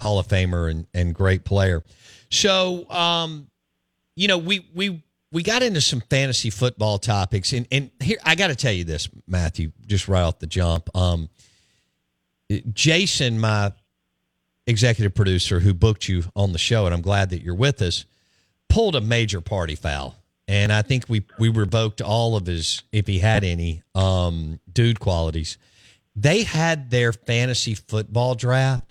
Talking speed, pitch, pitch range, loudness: 165 wpm, 105 Hz, 90-125 Hz, -21 LUFS